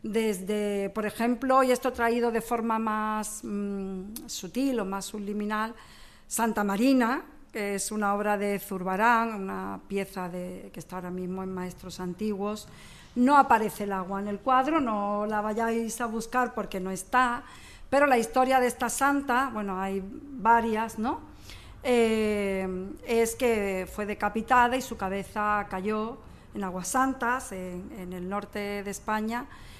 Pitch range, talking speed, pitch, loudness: 195-235 Hz, 150 wpm, 215 Hz, -28 LUFS